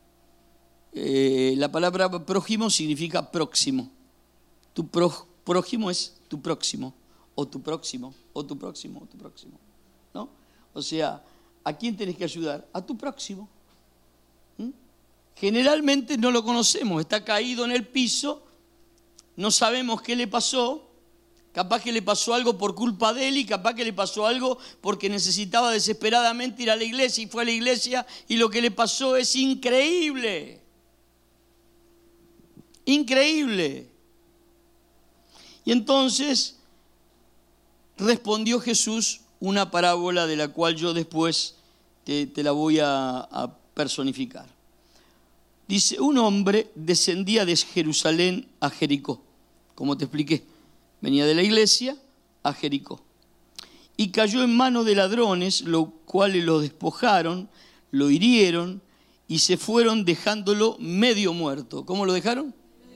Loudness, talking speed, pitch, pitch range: -23 LUFS, 130 wpm, 210 Hz, 170-240 Hz